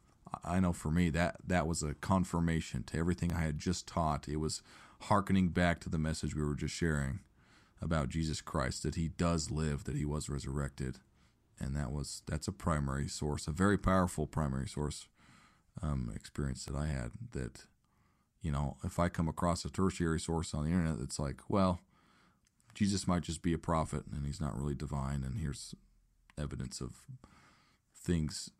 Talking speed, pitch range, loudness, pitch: 180 wpm, 70-85 Hz, -36 LUFS, 80 Hz